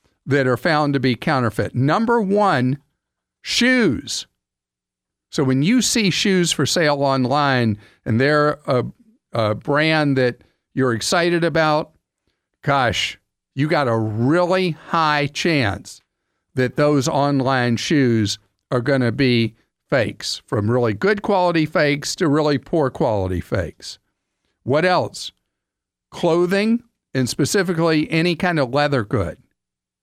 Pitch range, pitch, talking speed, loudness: 120-170 Hz, 145 Hz, 125 wpm, -19 LUFS